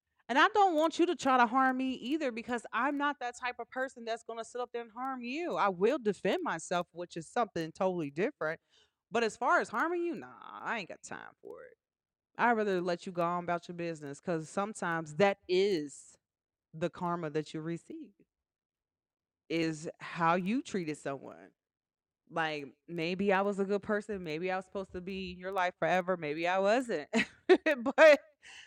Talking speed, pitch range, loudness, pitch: 195 wpm, 170-255 Hz, -32 LUFS, 195 Hz